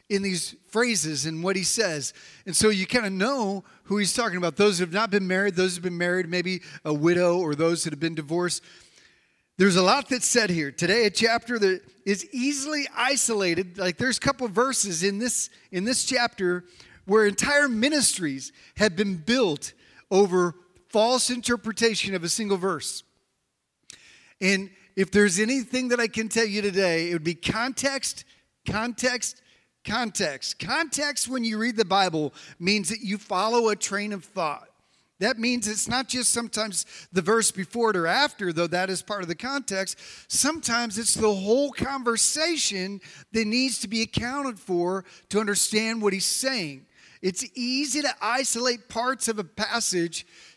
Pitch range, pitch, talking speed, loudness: 185-240 Hz, 210 Hz, 175 wpm, -24 LUFS